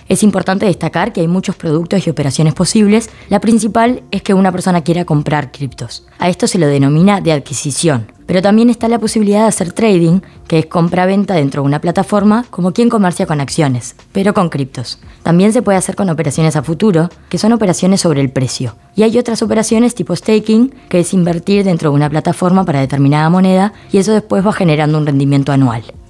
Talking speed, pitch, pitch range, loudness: 200 wpm, 180 Hz, 150-205 Hz, -12 LUFS